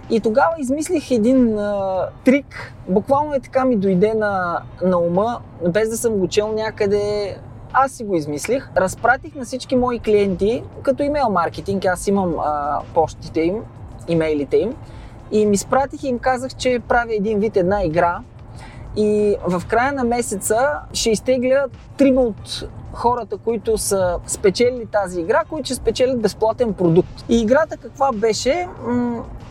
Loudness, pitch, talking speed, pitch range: -19 LUFS, 215 Hz, 155 wpm, 180-250 Hz